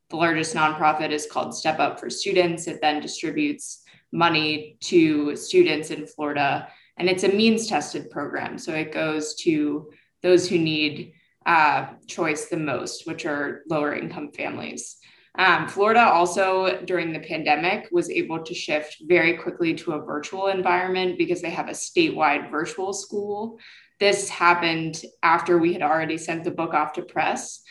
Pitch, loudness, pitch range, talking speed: 170 Hz, -23 LUFS, 155-195 Hz, 160 wpm